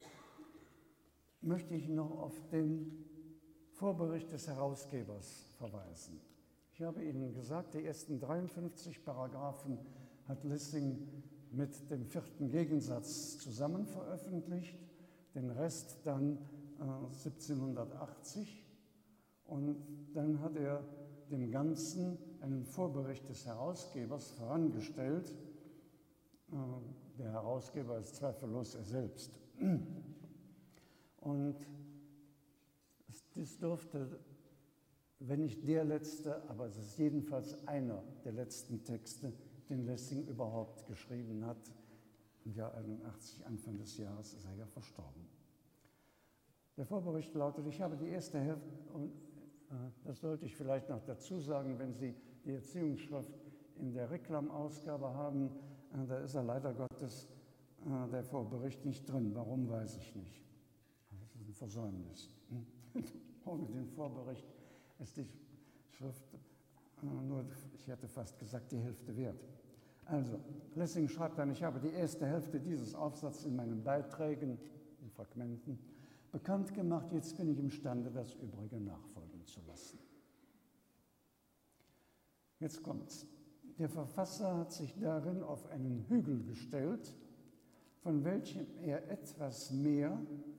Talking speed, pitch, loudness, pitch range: 115 wpm, 140 Hz, -43 LUFS, 125-155 Hz